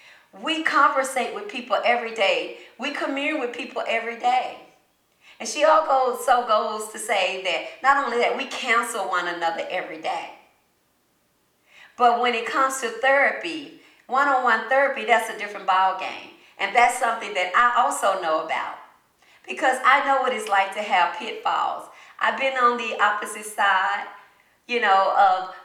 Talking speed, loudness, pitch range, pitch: 160 wpm, -22 LUFS, 200-270 Hz, 240 Hz